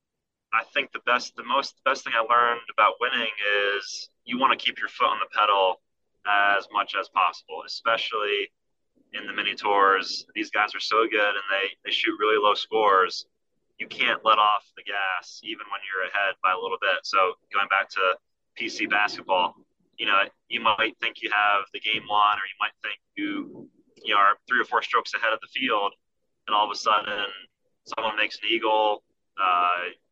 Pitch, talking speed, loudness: 115 Hz, 200 wpm, -24 LUFS